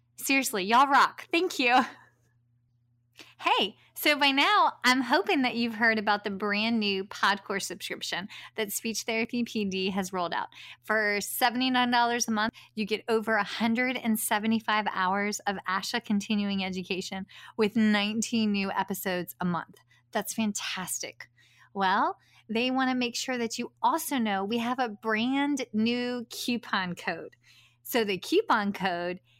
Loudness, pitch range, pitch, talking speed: -27 LUFS, 195-245 Hz, 220 Hz, 140 wpm